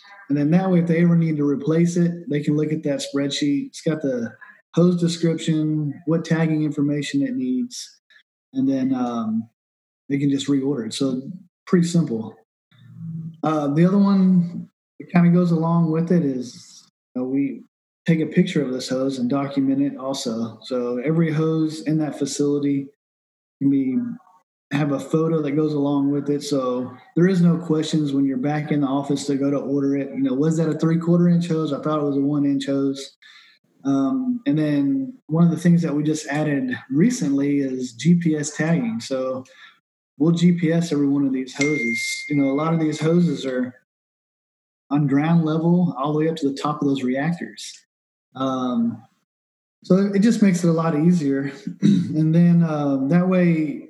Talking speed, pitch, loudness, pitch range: 190 wpm, 150 Hz, -21 LUFS, 140-170 Hz